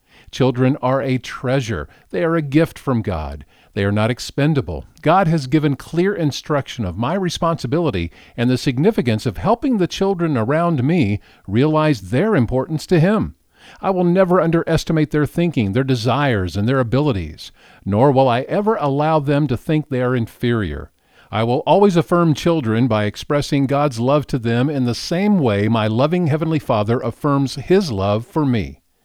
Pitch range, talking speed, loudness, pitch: 115-160 Hz, 170 wpm, -18 LUFS, 135 Hz